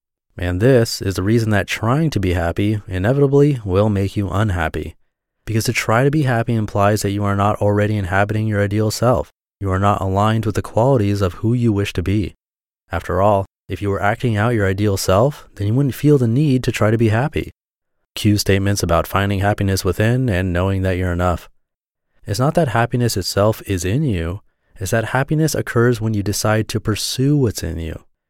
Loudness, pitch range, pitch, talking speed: -18 LUFS, 95-115 Hz, 105 Hz, 205 wpm